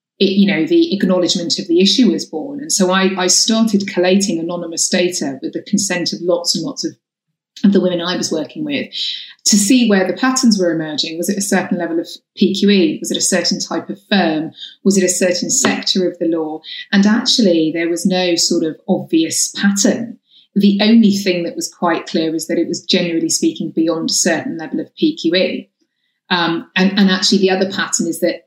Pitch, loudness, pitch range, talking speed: 185 Hz, -15 LUFS, 170-205 Hz, 210 wpm